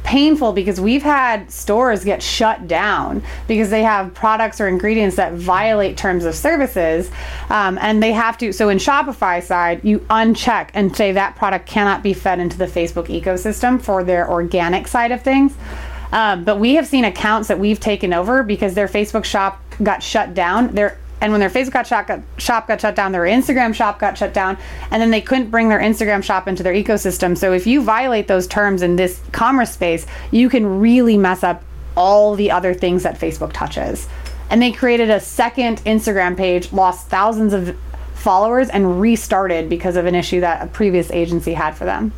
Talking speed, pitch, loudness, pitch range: 200 wpm, 205 Hz, -16 LUFS, 185-225 Hz